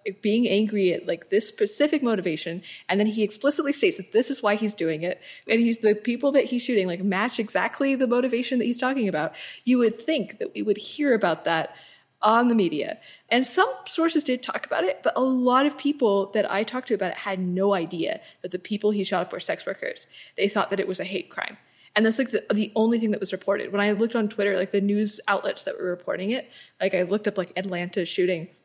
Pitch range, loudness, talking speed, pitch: 190-250 Hz, -25 LUFS, 240 wpm, 210 Hz